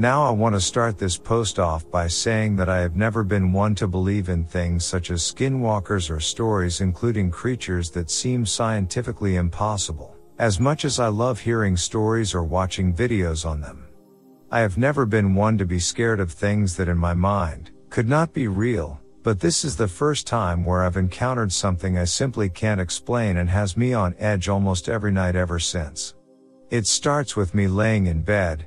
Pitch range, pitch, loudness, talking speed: 90-115 Hz, 100 Hz, -22 LUFS, 195 wpm